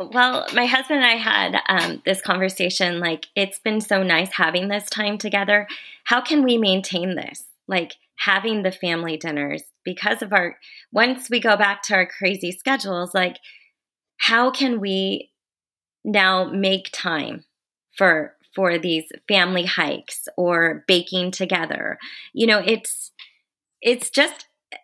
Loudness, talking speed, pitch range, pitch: -20 LUFS, 145 wpm, 185-240 Hz, 195 Hz